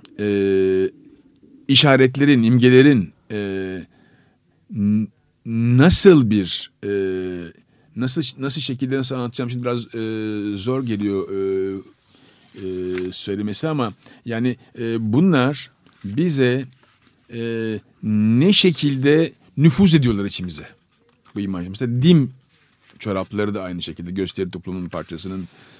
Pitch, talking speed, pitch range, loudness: 115 Hz, 95 wpm, 95-135 Hz, -19 LUFS